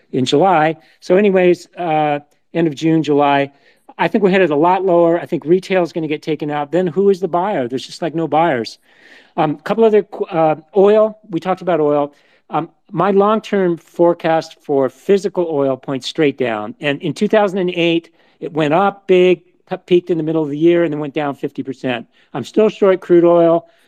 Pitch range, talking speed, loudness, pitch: 150-185 Hz, 200 wpm, -16 LUFS, 170 Hz